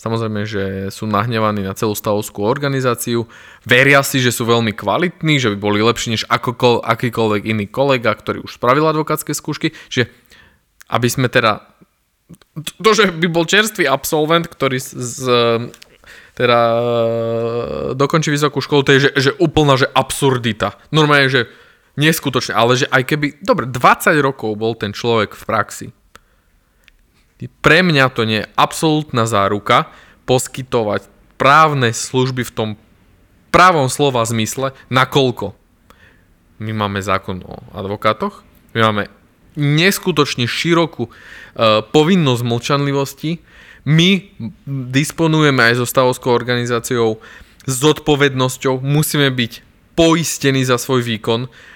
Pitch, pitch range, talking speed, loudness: 125 Hz, 115-145 Hz, 125 wpm, -15 LUFS